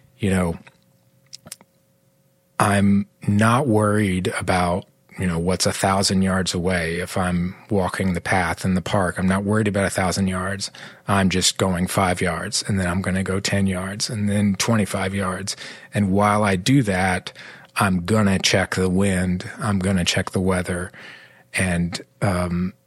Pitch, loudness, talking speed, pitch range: 95 Hz, -21 LUFS, 170 wpm, 90-100 Hz